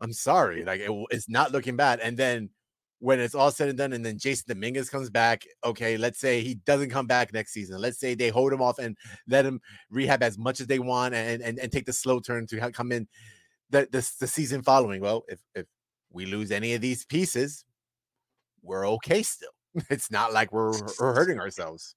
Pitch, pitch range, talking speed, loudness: 125 Hz, 115-135 Hz, 220 wpm, -27 LUFS